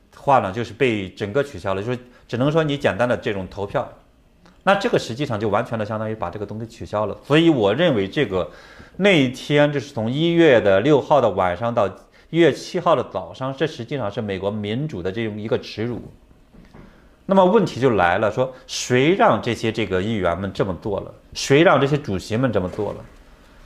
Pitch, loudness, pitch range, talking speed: 115 Hz, -20 LUFS, 100-140 Hz, 305 characters per minute